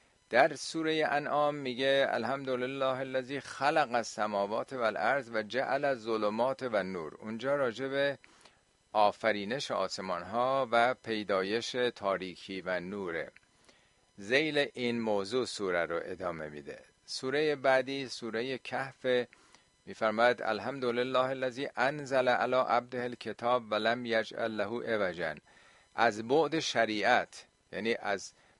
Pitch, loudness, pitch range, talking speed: 125 Hz, -32 LUFS, 110-135 Hz, 110 wpm